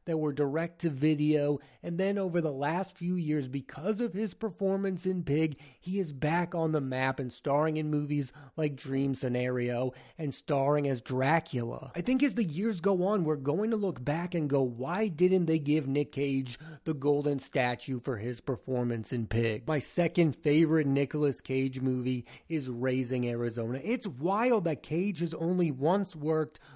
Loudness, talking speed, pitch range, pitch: -31 LUFS, 180 wpm, 135-175 Hz, 150 Hz